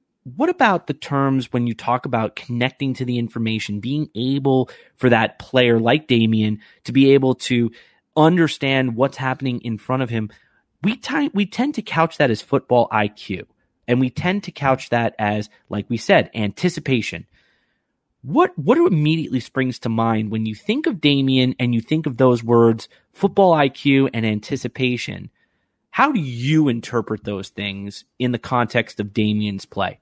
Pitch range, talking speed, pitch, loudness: 115-145 Hz, 170 wpm, 125 Hz, -20 LUFS